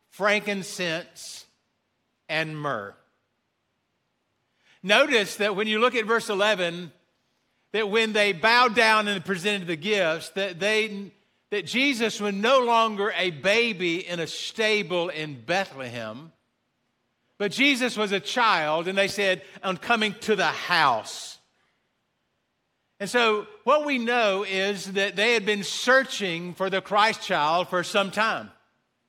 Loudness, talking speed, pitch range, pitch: -24 LUFS, 135 wpm, 175-215 Hz, 200 Hz